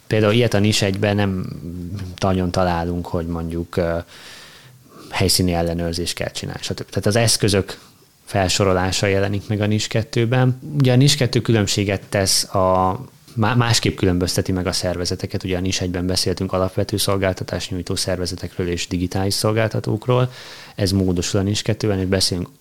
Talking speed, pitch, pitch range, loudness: 145 wpm, 100 Hz, 90-110 Hz, -20 LUFS